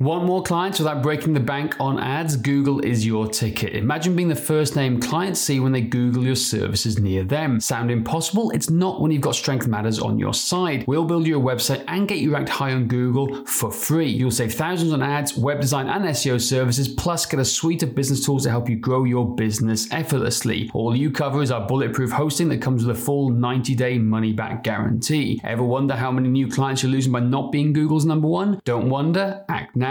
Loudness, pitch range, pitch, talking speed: -21 LUFS, 120-150 Hz, 135 Hz, 225 wpm